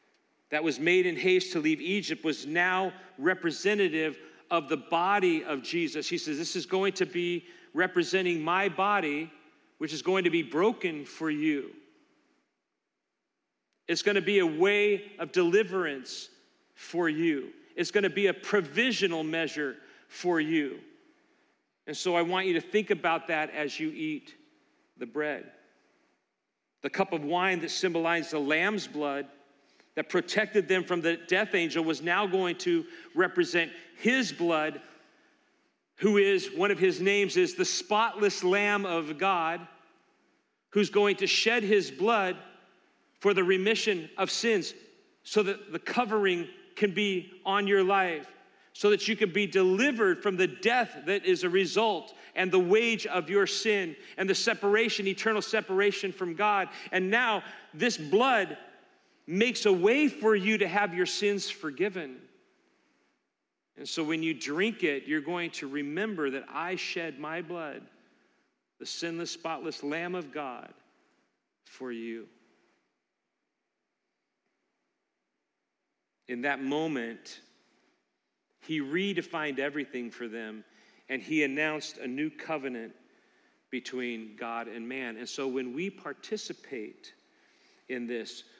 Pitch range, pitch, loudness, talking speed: 160-225 Hz, 190 Hz, -29 LUFS, 140 wpm